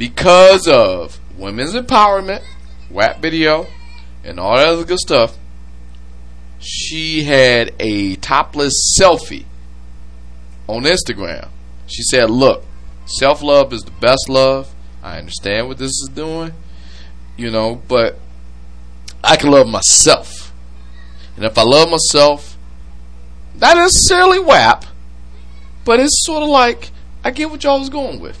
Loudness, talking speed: -12 LUFS, 130 wpm